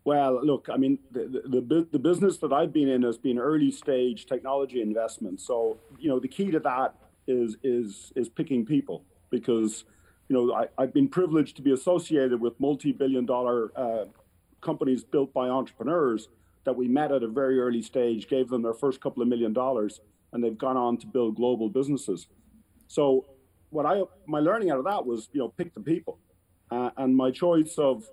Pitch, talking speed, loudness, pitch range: 130 Hz, 195 wpm, -27 LUFS, 120-150 Hz